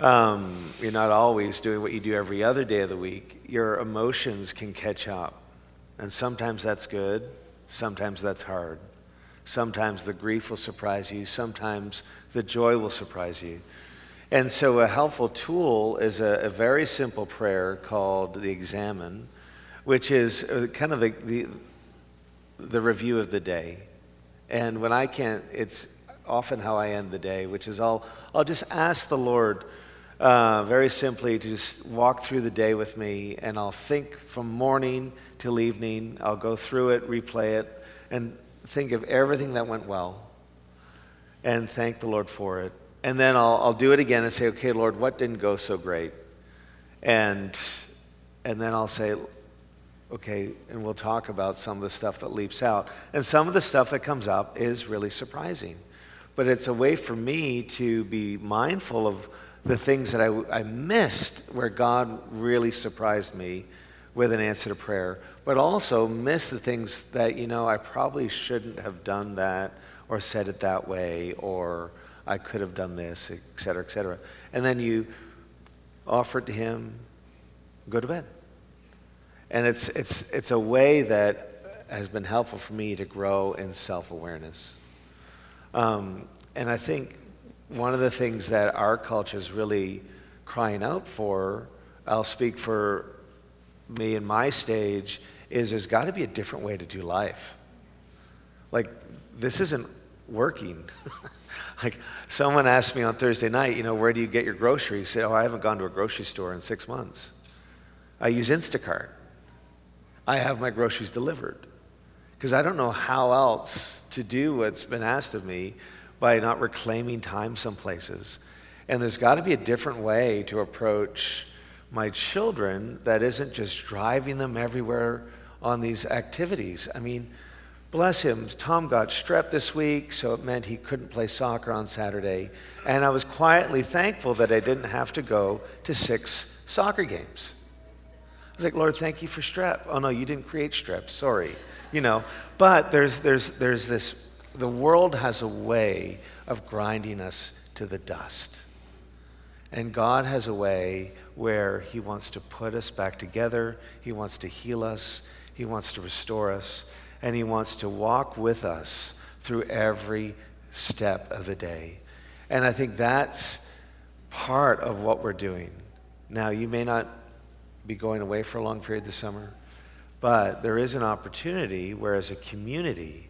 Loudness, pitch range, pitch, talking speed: -26 LUFS, 90-120 Hz, 110 Hz, 170 wpm